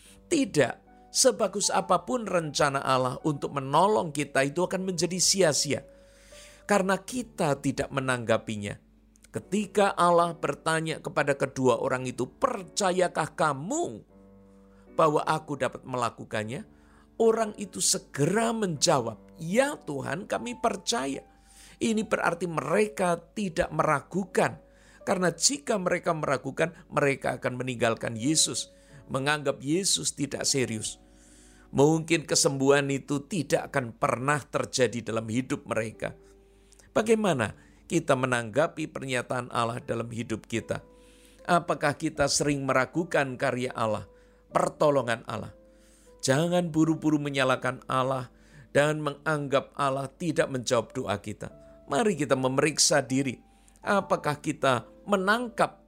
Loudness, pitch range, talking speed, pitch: -27 LUFS, 125-175 Hz, 105 wpm, 145 Hz